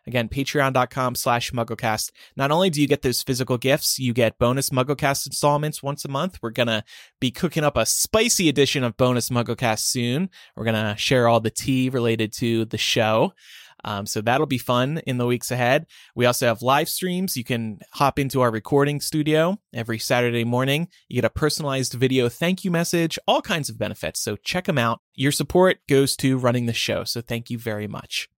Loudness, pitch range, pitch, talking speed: -22 LUFS, 115-145 Hz, 125 Hz, 205 wpm